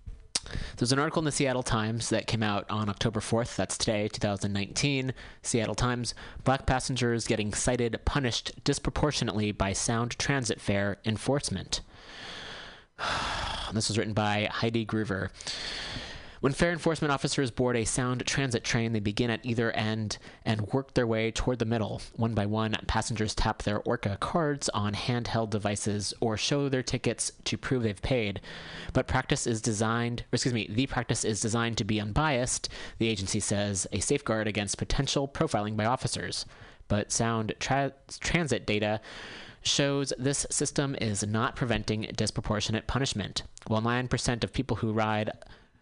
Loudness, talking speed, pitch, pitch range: -30 LUFS, 155 wpm, 115 Hz, 105-130 Hz